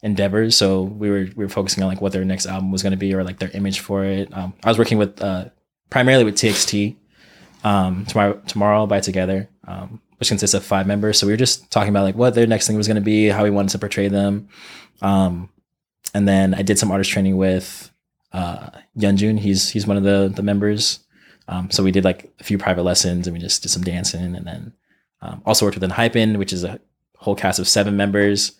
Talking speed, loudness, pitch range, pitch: 235 wpm, -18 LUFS, 95-105 Hz, 100 Hz